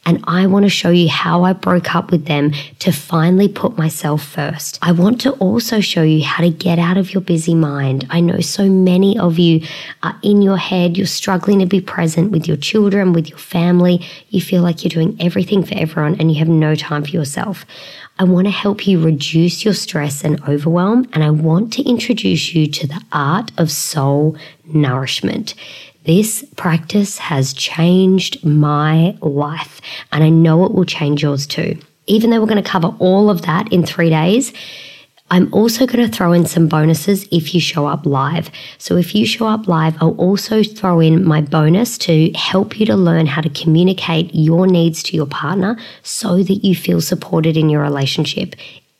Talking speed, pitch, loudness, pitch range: 195 wpm, 170 Hz, -14 LUFS, 155-190 Hz